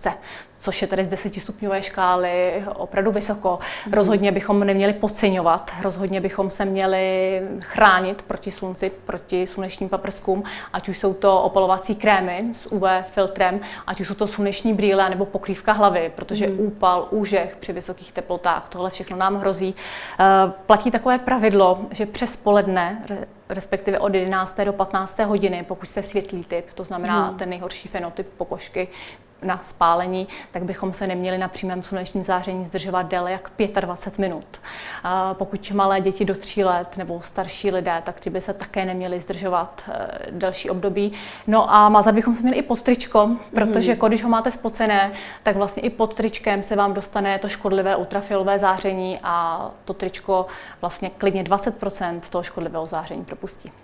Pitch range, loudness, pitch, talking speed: 185-205 Hz, -21 LUFS, 195 Hz, 160 wpm